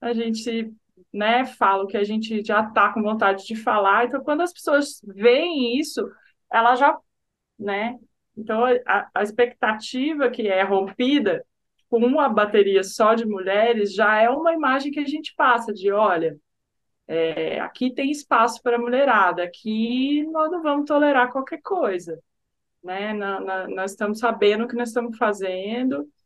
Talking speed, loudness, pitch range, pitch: 160 wpm, -21 LUFS, 200-255 Hz, 225 Hz